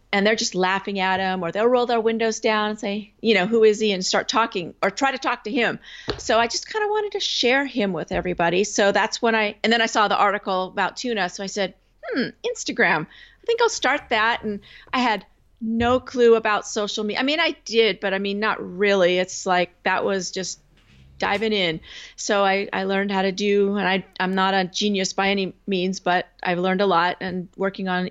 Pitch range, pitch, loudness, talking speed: 190-230 Hz, 205 Hz, -22 LUFS, 235 wpm